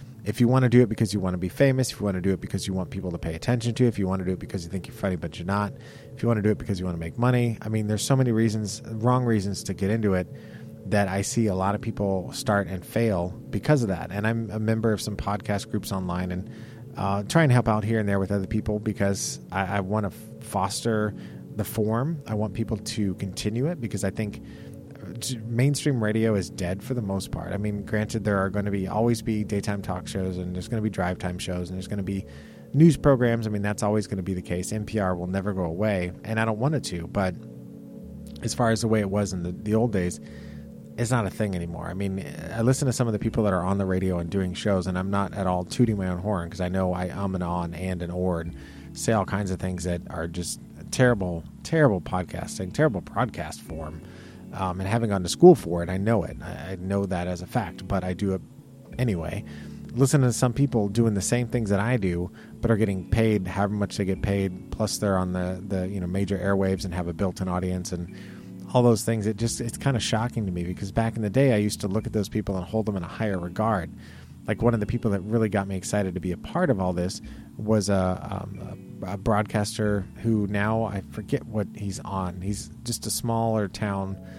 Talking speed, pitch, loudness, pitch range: 255 wpm, 100 Hz, -26 LUFS, 95-110 Hz